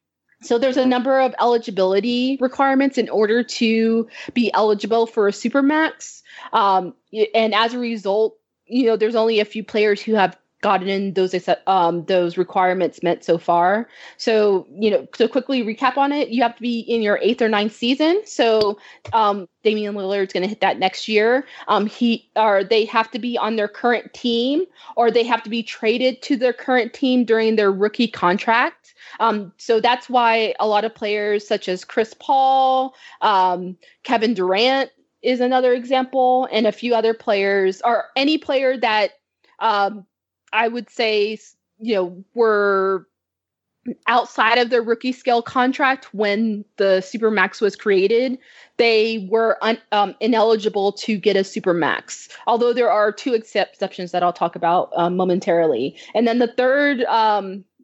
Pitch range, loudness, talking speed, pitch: 200-245 Hz, -19 LUFS, 165 wpm, 225 Hz